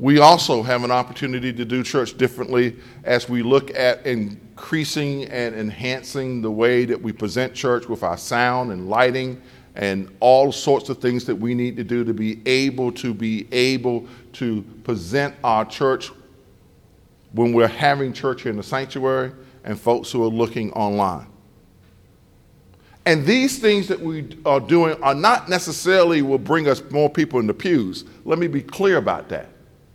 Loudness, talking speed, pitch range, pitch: -20 LUFS, 170 wpm, 115-140 Hz, 125 Hz